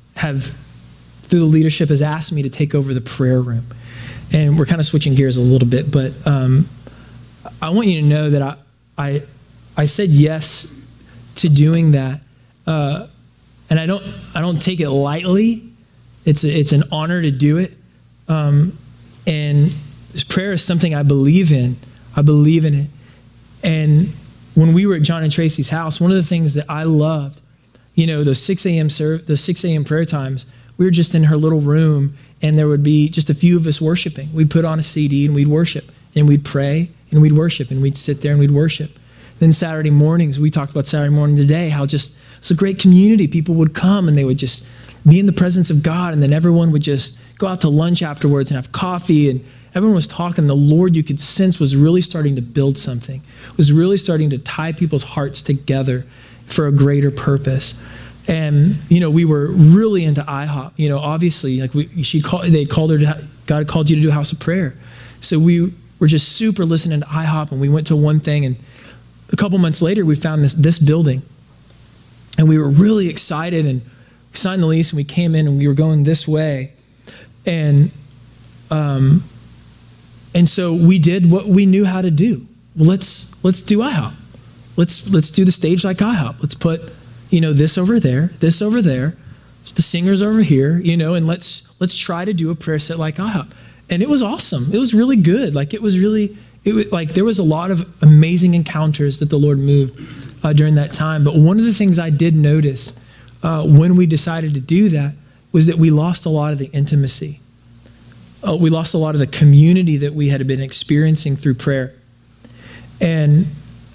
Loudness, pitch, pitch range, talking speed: -15 LUFS, 150 Hz, 140-170 Hz, 210 wpm